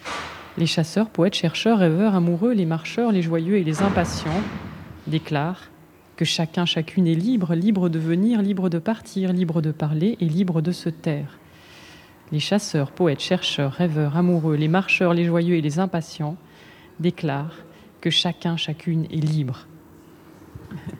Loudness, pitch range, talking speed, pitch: -22 LUFS, 160-185 Hz, 150 wpm, 170 Hz